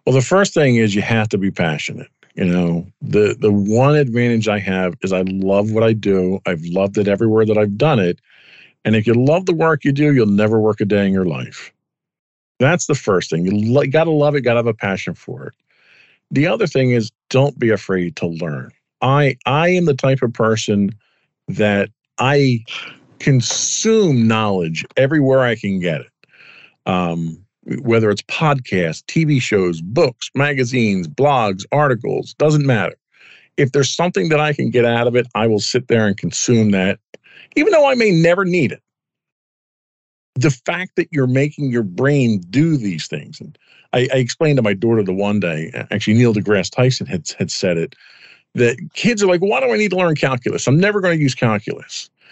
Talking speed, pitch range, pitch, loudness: 195 wpm, 105-145 Hz, 120 Hz, -16 LUFS